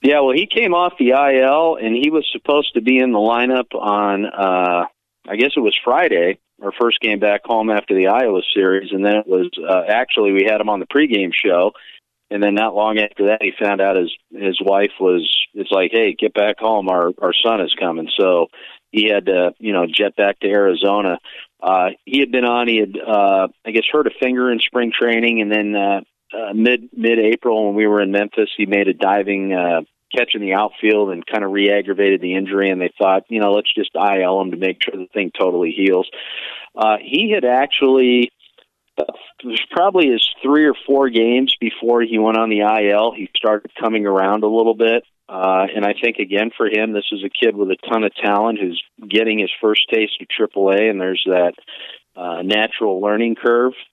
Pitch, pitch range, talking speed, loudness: 105 Hz, 100-115 Hz, 215 wpm, -16 LUFS